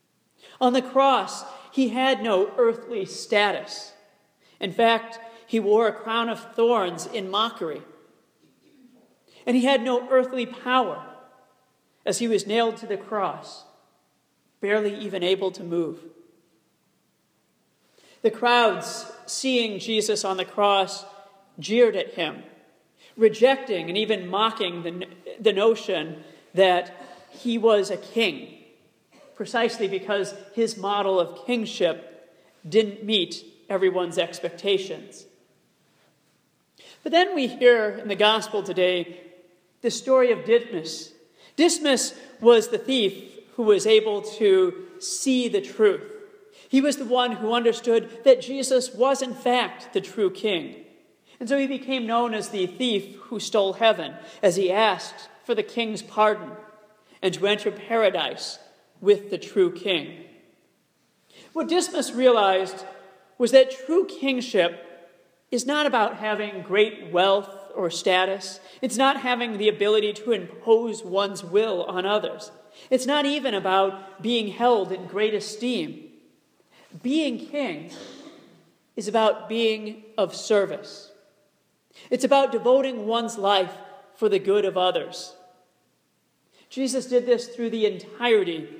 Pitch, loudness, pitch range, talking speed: 215 Hz, -23 LUFS, 195-250 Hz, 130 wpm